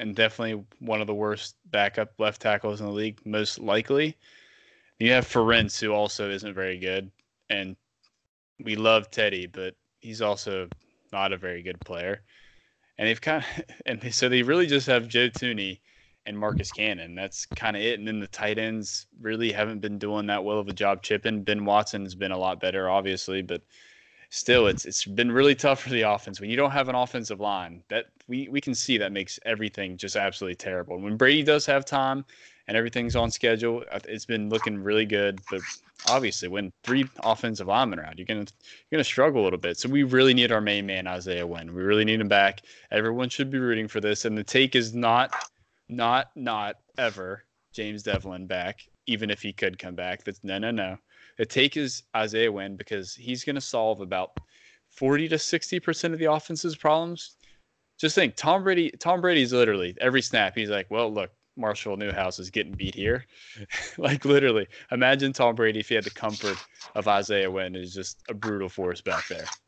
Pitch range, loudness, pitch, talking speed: 100-125 Hz, -26 LUFS, 110 Hz, 200 wpm